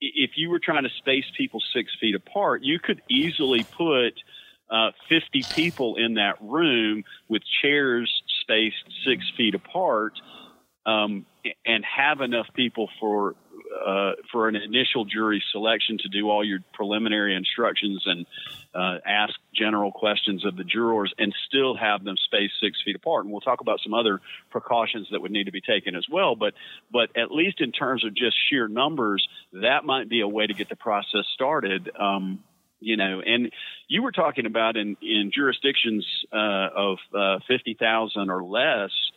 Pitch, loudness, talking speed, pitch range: 110 Hz, -24 LUFS, 175 wpm, 100-120 Hz